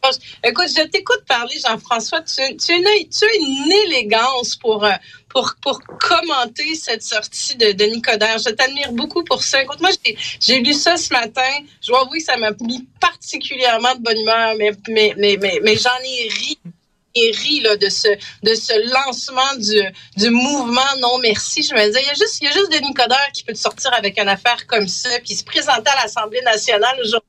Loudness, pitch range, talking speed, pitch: -16 LUFS, 220-285 Hz, 200 wpm, 250 Hz